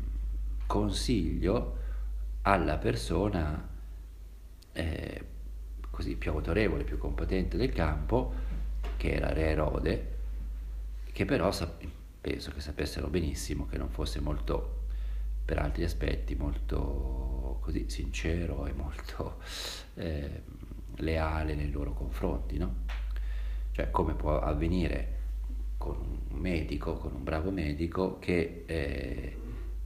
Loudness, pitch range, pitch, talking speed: -34 LUFS, 65-85 Hz, 75 Hz, 105 wpm